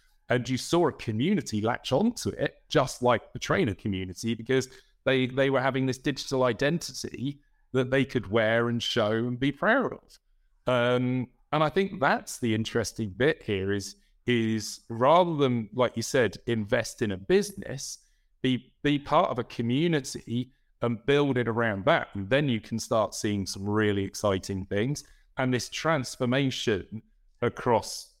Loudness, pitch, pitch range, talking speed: -28 LUFS, 125 Hz, 110-135 Hz, 160 wpm